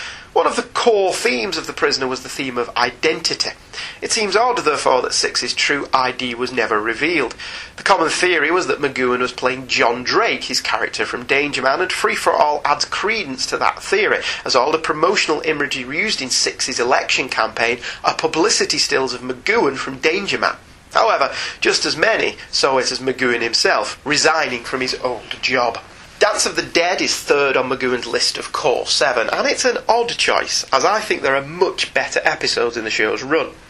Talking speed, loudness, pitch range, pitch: 195 wpm, -17 LUFS, 125-190 Hz, 130 Hz